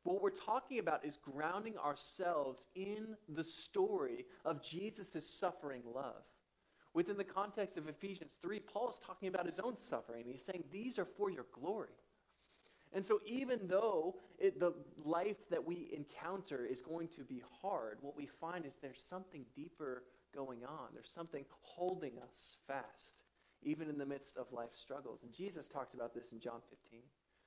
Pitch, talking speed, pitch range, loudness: 170 Hz, 170 wpm, 140-195 Hz, -44 LUFS